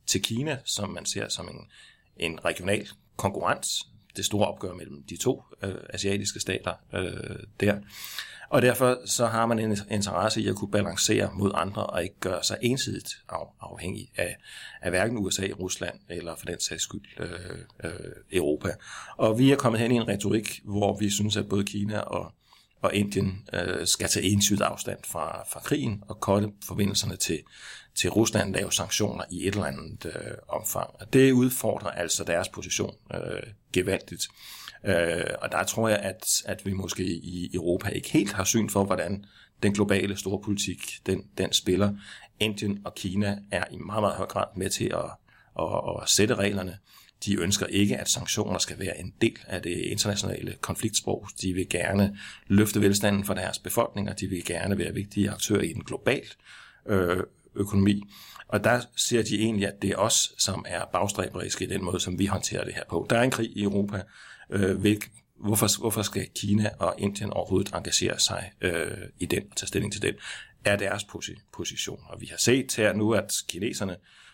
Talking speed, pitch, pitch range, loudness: 180 wpm, 100 Hz, 95-105 Hz, -27 LUFS